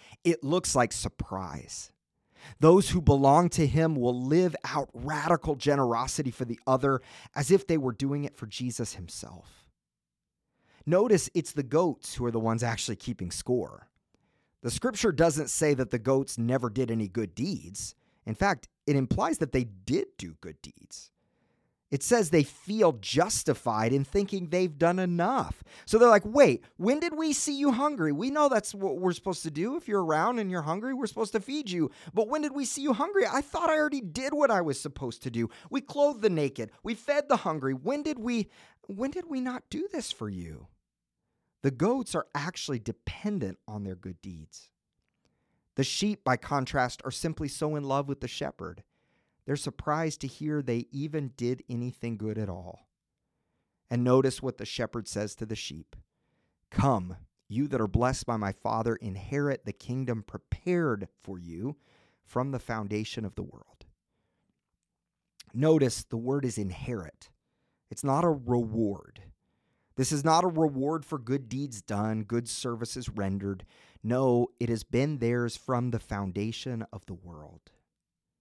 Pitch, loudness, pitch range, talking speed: 135 Hz, -29 LUFS, 115-175 Hz, 175 wpm